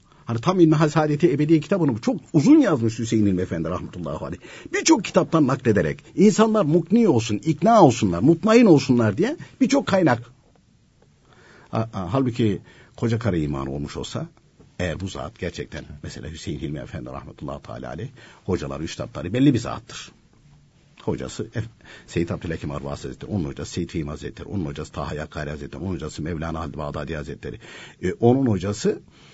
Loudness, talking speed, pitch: -22 LUFS, 150 wpm, 115 Hz